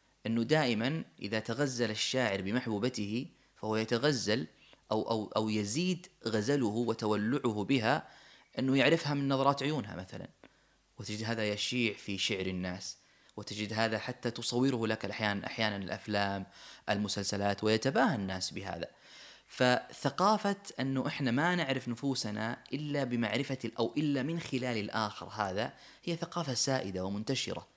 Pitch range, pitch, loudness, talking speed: 105-135 Hz, 115 Hz, -33 LUFS, 125 wpm